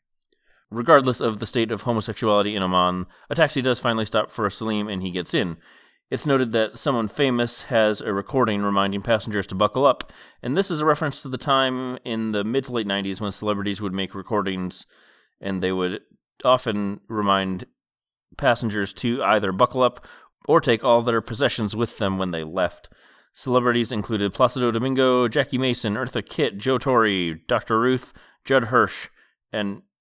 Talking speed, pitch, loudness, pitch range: 175 wpm, 110 Hz, -22 LUFS, 100-125 Hz